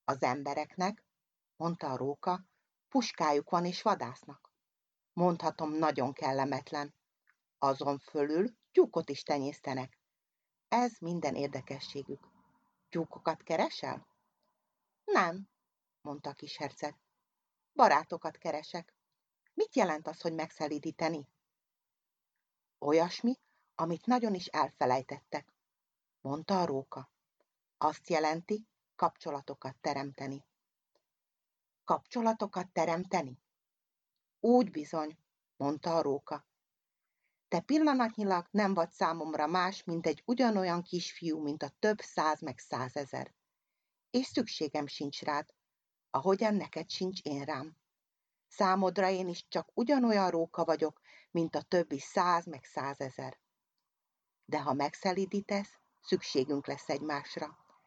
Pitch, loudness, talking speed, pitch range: 165 Hz, -34 LUFS, 100 wpm, 145-195 Hz